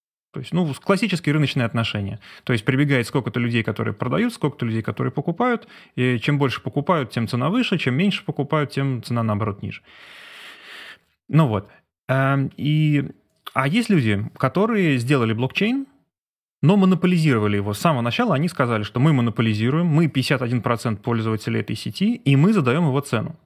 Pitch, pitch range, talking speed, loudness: 135 Hz, 120-165 Hz, 155 wpm, -21 LUFS